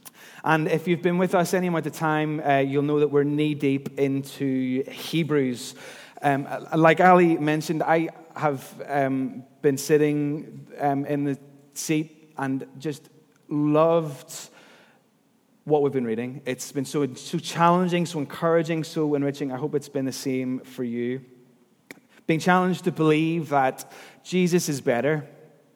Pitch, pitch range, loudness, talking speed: 150 Hz, 140-165 Hz, -24 LUFS, 150 wpm